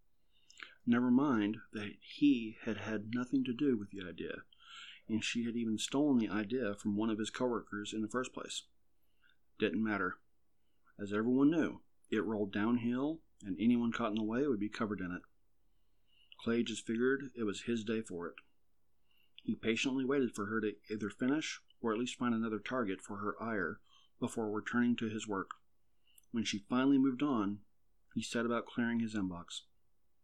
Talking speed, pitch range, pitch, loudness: 175 wpm, 105-125 Hz, 115 Hz, -36 LUFS